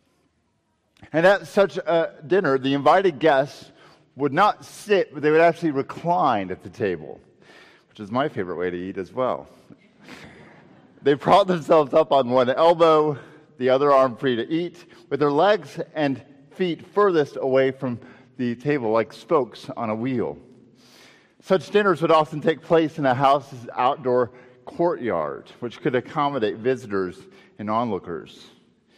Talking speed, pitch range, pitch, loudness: 150 wpm, 130-165 Hz, 140 Hz, -22 LUFS